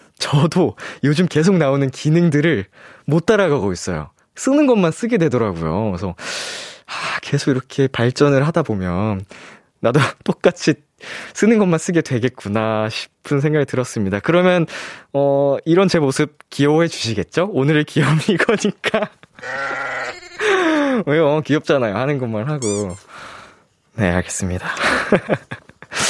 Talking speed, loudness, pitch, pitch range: 275 characters per minute, -18 LUFS, 145 Hz, 115-175 Hz